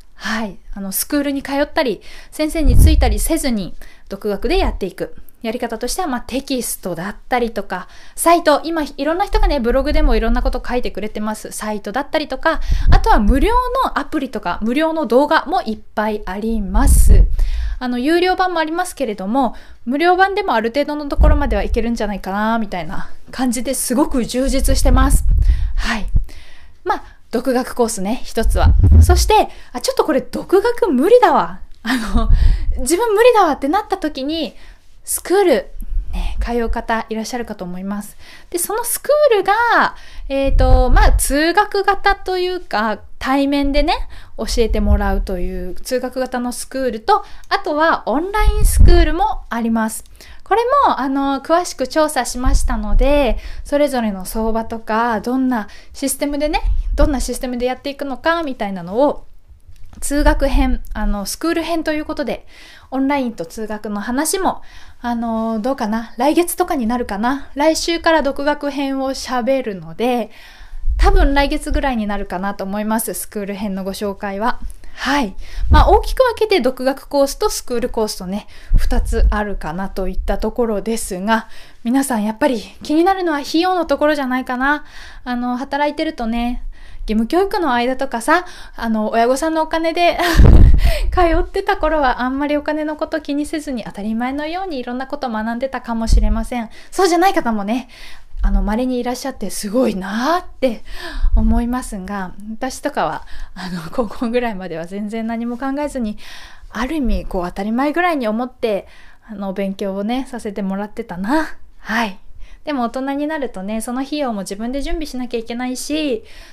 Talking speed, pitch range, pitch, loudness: 350 characters per minute, 220-310 Hz, 255 Hz, -18 LUFS